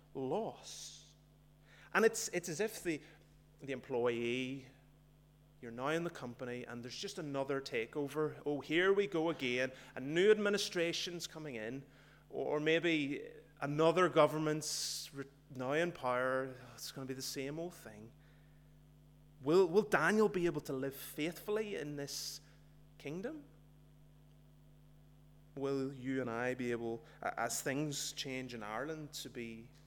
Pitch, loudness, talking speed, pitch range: 145 Hz, -37 LUFS, 140 wpm, 135-160 Hz